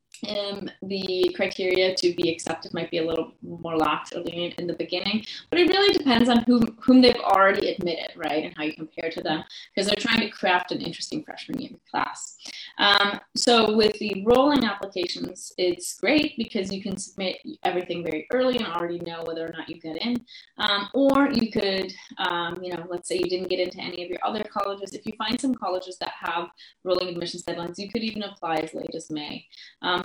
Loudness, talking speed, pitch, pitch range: -25 LUFS, 215 wpm, 185 Hz, 170-220 Hz